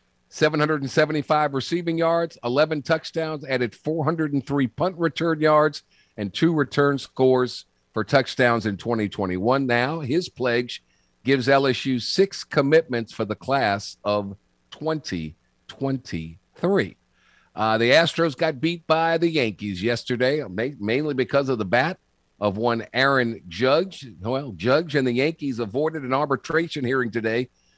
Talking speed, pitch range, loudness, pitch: 125 wpm, 115-155 Hz, -23 LUFS, 135 Hz